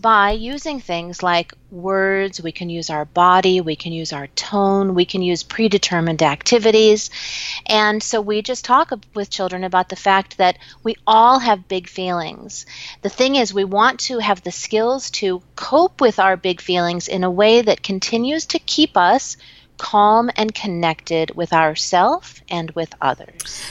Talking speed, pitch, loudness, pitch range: 170 wpm, 195 Hz, -17 LUFS, 175-225 Hz